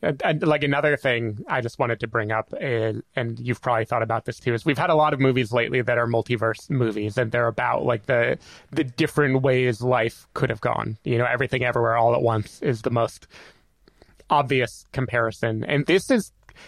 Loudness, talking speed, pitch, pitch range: -23 LUFS, 210 wpm, 120 Hz, 115-135 Hz